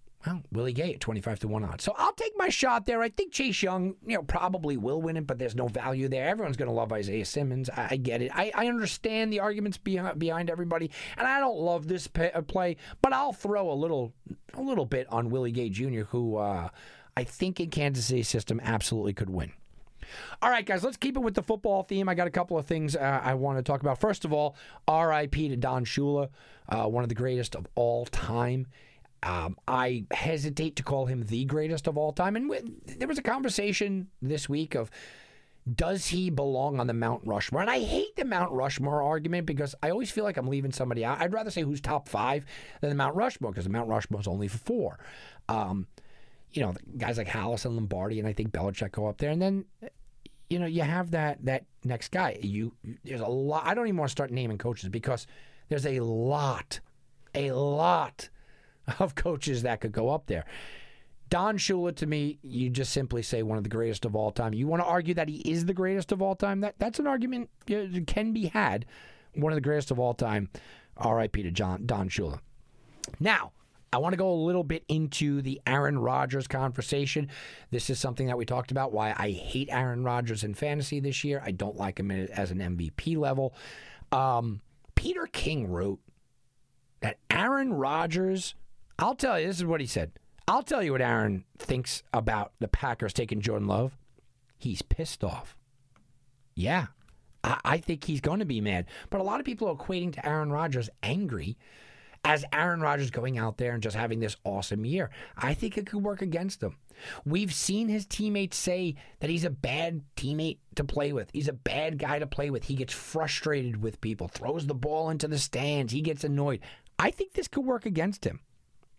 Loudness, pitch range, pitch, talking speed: -30 LUFS, 120-175 Hz, 140 Hz, 210 wpm